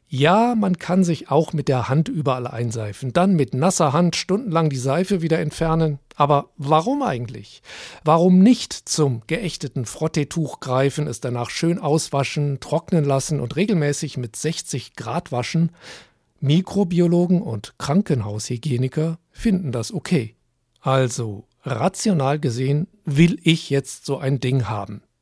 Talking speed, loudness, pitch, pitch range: 135 wpm, -21 LUFS, 150 Hz, 130-170 Hz